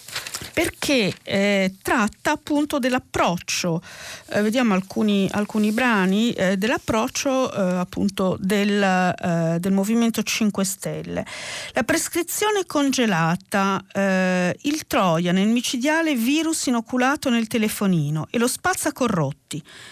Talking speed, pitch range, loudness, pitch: 110 wpm, 185-260 Hz, -22 LUFS, 210 Hz